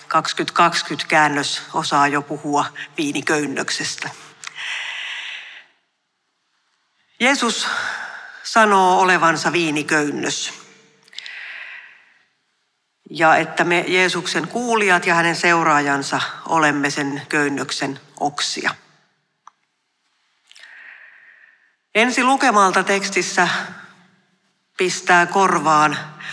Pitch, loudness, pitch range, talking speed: 175 Hz, -18 LUFS, 150-195 Hz, 60 wpm